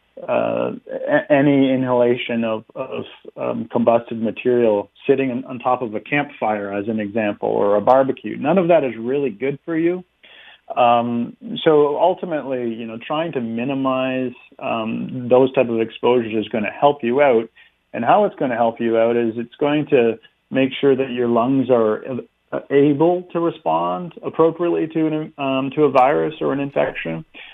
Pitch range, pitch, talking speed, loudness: 115-145 Hz, 125 Hz, 170 wpm, -19 LUFS